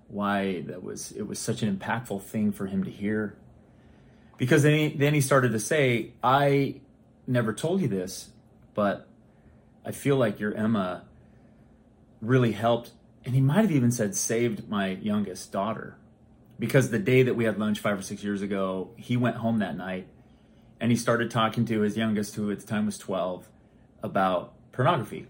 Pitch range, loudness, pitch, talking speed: 105-120 Hz, -27 LUFS, 110 Hz, 180 wpm